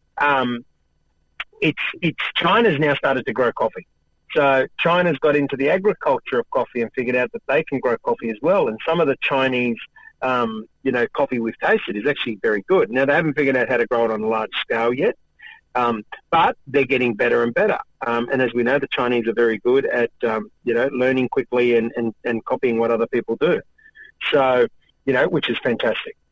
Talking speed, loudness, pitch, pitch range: 210 wpm, -20 LUFS, 125 Hz, 115-150 Hz